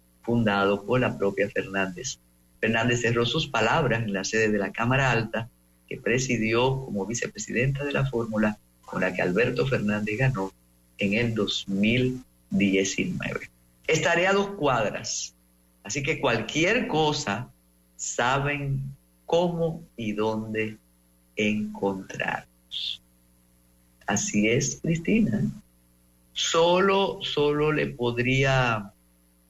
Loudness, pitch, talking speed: -25 LUFS, 110 Hz, 105 wpm